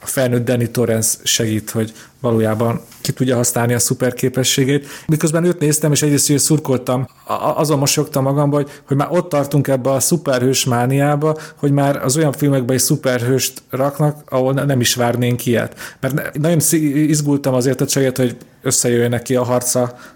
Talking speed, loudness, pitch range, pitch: 165 wpm, -16 LUFS, 125-145 Hz, 135 Hz